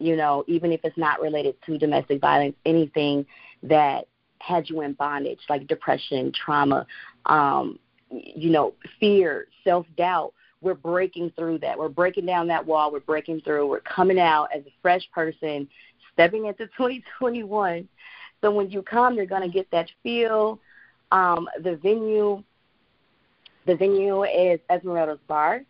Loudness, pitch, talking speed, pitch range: -23 LUFS, 175 Hz, 150 wpm, 155-200 Hz